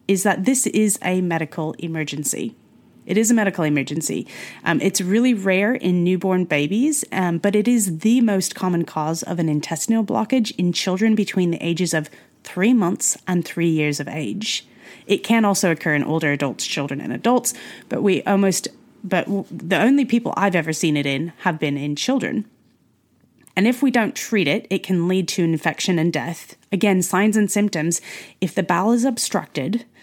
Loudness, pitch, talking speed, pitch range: -20 LUFS, 185 Hz, 185 wpm, 165-215 Hz